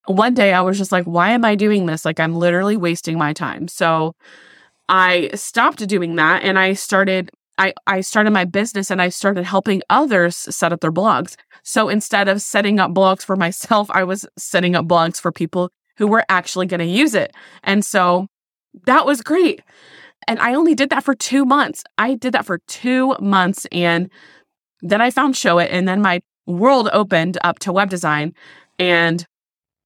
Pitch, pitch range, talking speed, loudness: 190 Hz, 175-215 Hz, 195 wpm, -17 LUFS